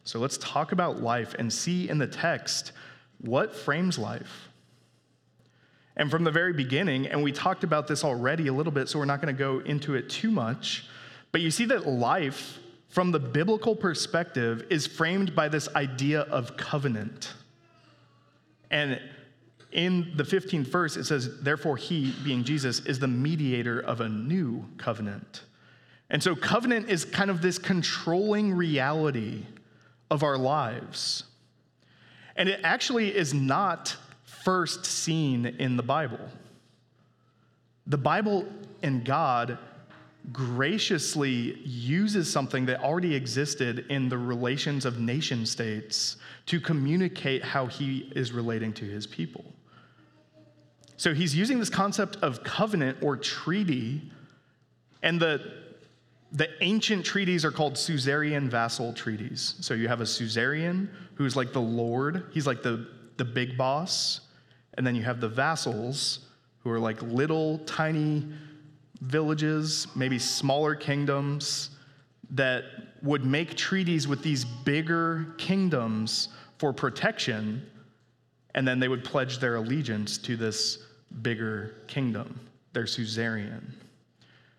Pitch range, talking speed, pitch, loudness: 125-160 Hz, 135 wpm, 140 Hz, -28 LUFS